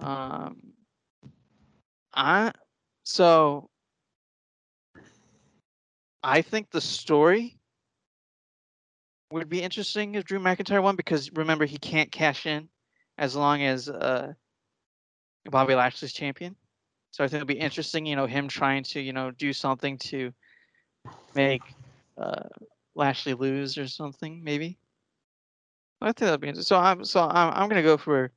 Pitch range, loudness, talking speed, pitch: 135-165 Hz, -26 LUFS, 135 wpm, 145 Hz